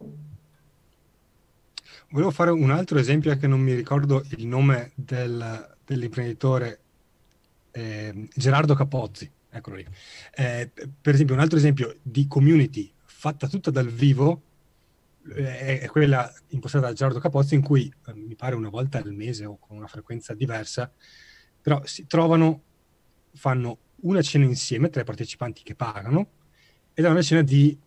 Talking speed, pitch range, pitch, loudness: 145 wpm, 120-150 Hz, 135 Hz, -23 LUFS